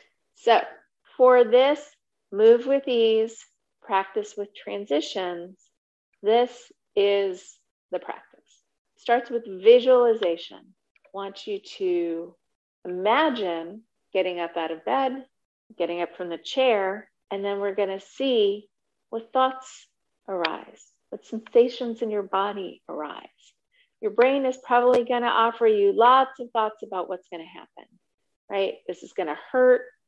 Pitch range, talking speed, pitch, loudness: 195-250 Hz, 130 wpm, 220 Hz, -23 LUFS